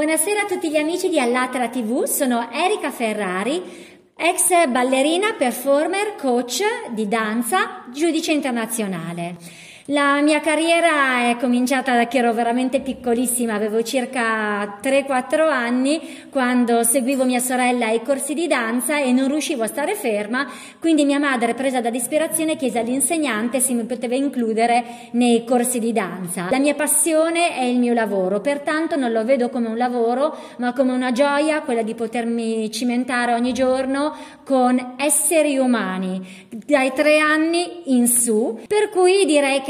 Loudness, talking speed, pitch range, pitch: -19 LUFS, 150 wpm, 235-300 Hz, 260 Hz